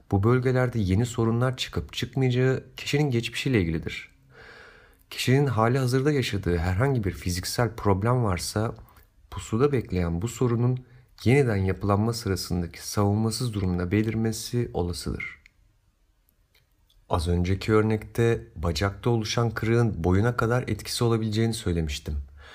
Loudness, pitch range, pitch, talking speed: -26 LUFS, 90-120 Hz, 110 Hz, 105 wpm